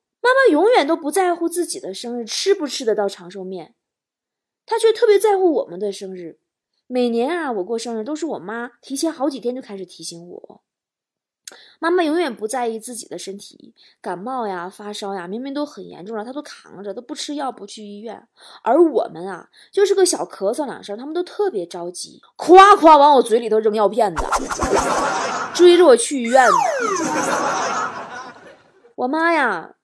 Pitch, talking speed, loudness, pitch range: 250 Hz, 260 characters per minute, -18 LUFS, 210-335 Hz